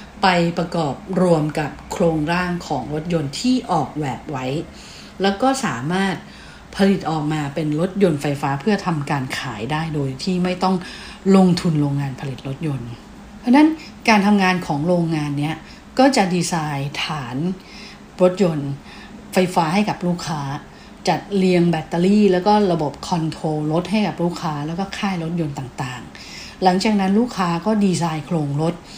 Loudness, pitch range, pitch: -20 LUFS, 150-195 Hz, 170 Hz